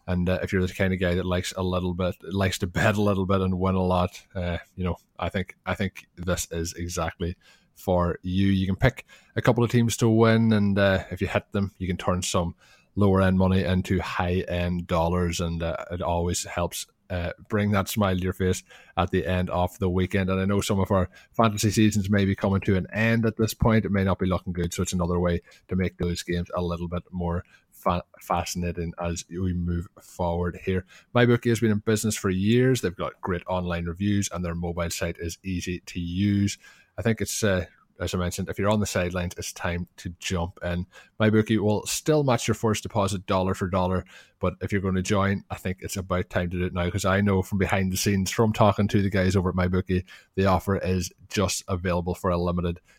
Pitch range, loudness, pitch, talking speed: 90-100 Hz, -26 LUFS, 95 Hz, 230 wpm